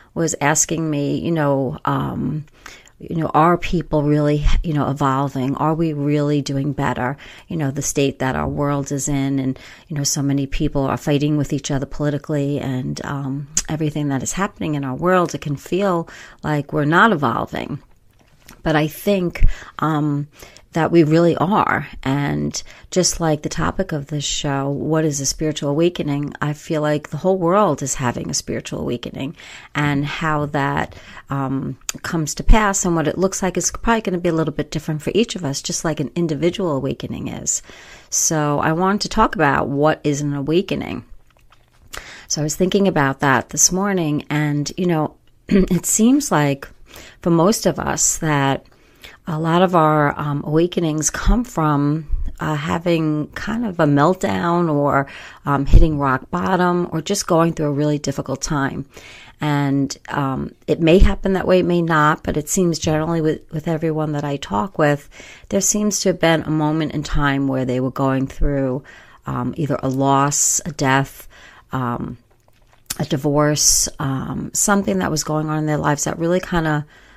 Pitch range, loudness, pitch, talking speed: 140-170 Hz, -19 LUFS, 150 Hz, 180 wpm